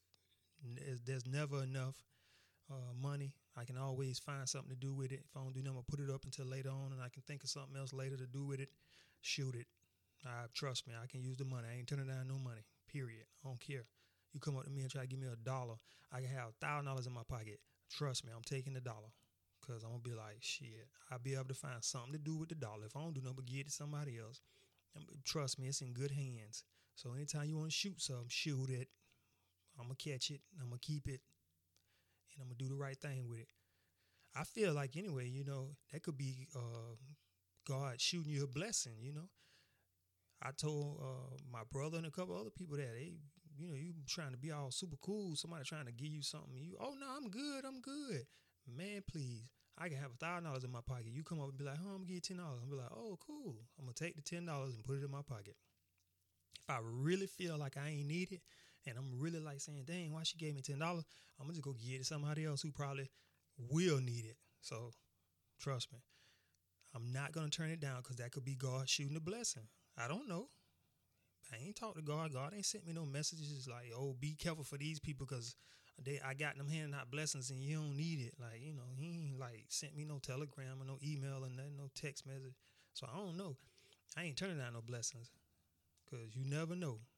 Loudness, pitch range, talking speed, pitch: -46 LUFS, 120-150 Hz, 245 wpm, 135 Hz